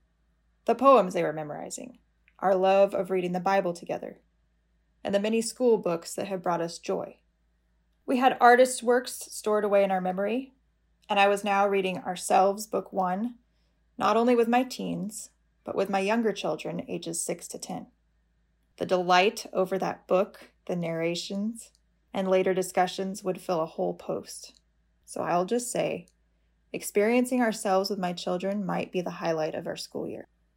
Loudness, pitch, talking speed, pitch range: -27 LUFS, 190 Hz, 165 wpm, 170-215 Hz